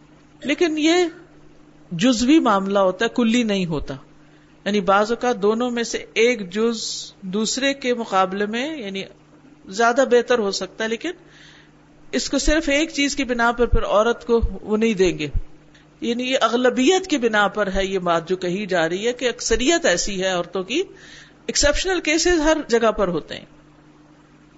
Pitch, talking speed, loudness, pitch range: 230 Hz, 175 wpm, -20 LUFS, 190-275 Hz